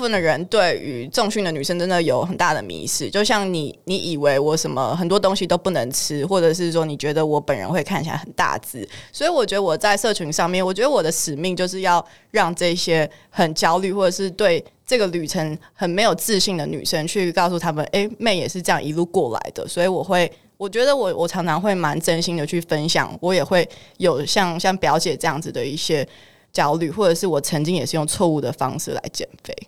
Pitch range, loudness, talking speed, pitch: 160-190 Hz, -20 LUFS, 330 characters per minute, 175 Hz